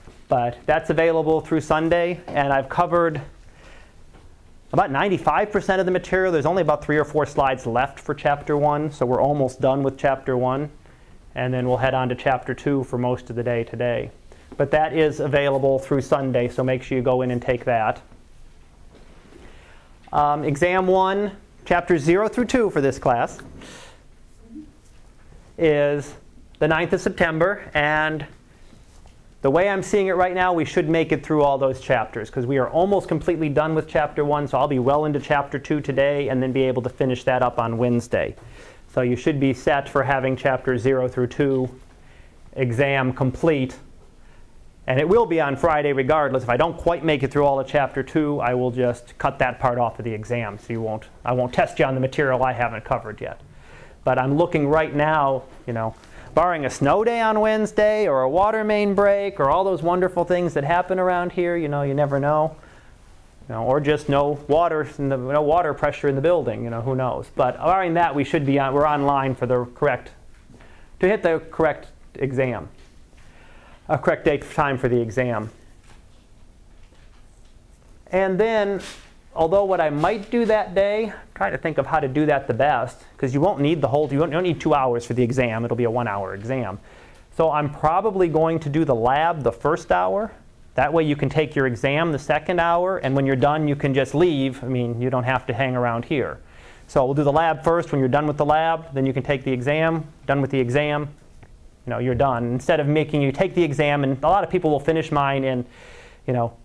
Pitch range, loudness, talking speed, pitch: 125-160 Hz, -21 LUFS, 205 wpm, 140 Hz